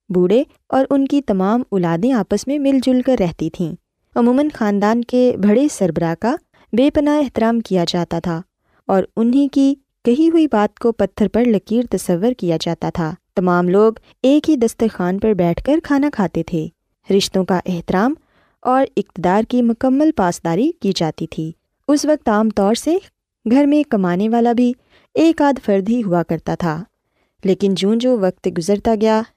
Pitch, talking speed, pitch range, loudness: 220 Hz, 170 wpm, 185-260 Hz, -17 LUFS